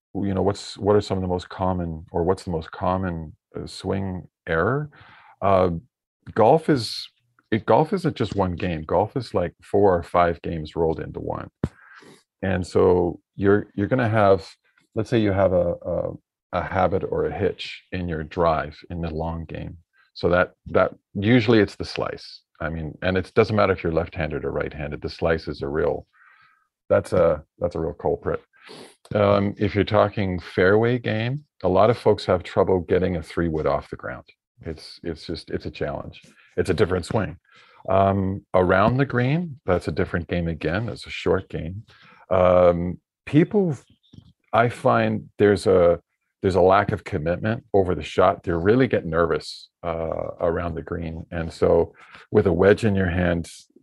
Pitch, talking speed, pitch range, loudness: 95 Hz, 180 wpm, 85-105 Hz, -23 LUFS